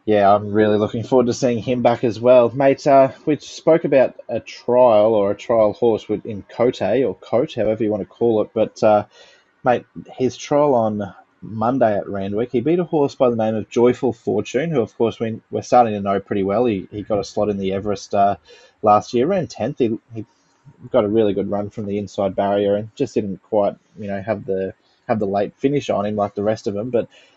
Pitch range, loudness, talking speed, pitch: 100-125 Hz, -19 LUFS, 230 wpm, 110 Hz